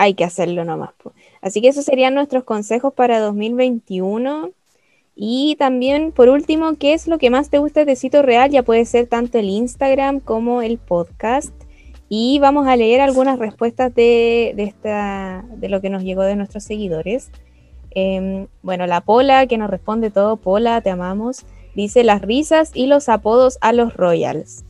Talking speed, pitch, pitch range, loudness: 175 wpm, 230 Hz, 200-265 Hz, -16 LUFS